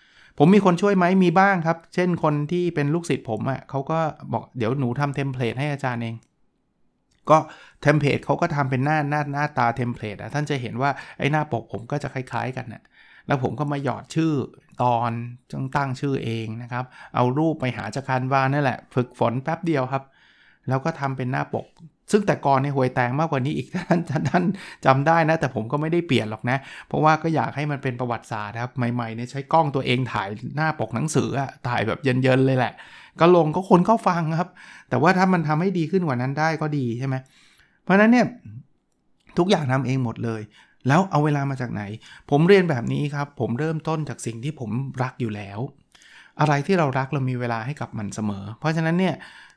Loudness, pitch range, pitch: -23 LUFS, 125-155 Hz, 140 Hz